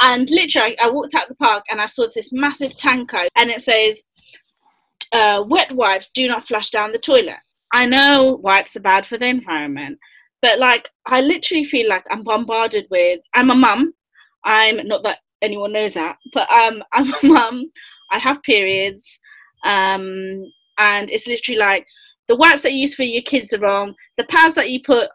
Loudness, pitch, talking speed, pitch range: -16 LUFS, 240 Hz, 190 wpm, 210-280 Hz